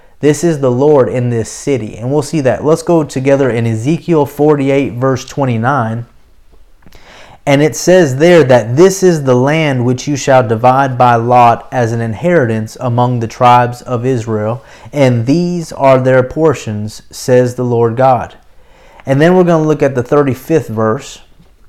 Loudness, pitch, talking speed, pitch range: -11 LUFS, 130 Hz, 170 wpm, 120-150 Hz